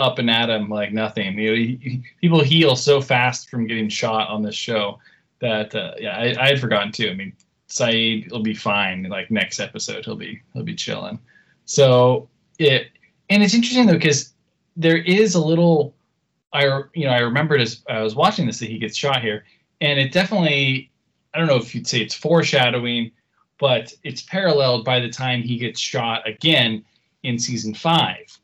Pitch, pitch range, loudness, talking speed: 125 Hz, 110-155 Hz, -19 LUFS, 195 wpm